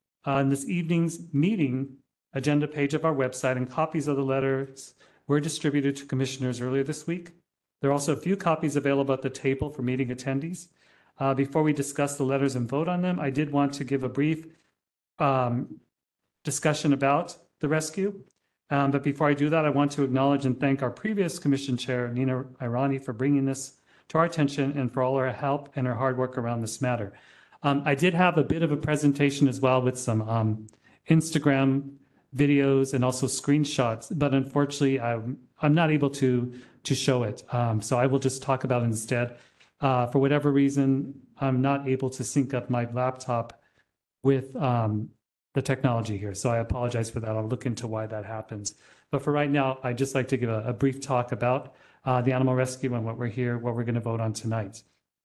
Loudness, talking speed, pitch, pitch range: -27 LUFS, 205 wpm, 135 Hz, 125-145 Hz